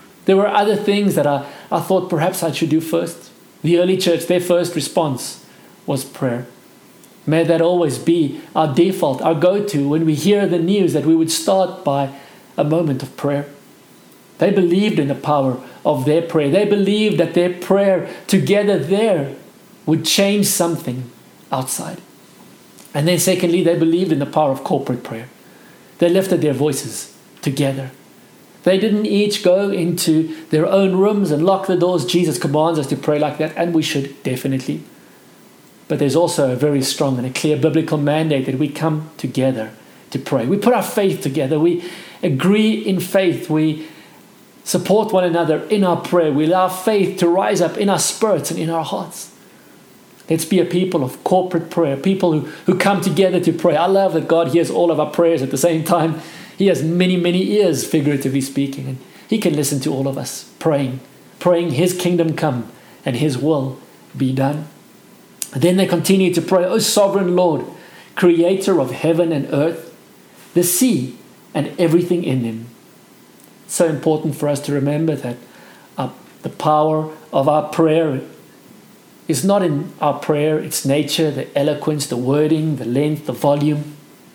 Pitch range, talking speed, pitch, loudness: 145-180 Hz, 175 wpm, 165 Hz, -17 LUFS